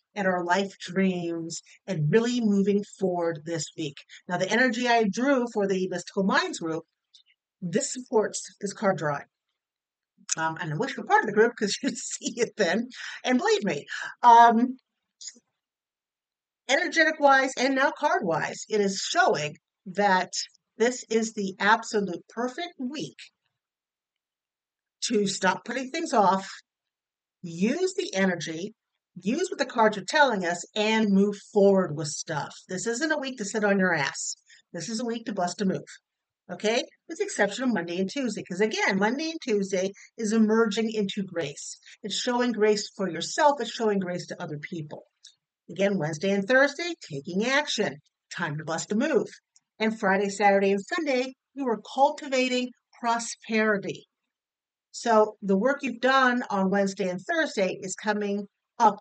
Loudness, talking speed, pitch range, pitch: -26 LUFS, 160 wpm, 190-245 Hz, 210 Hz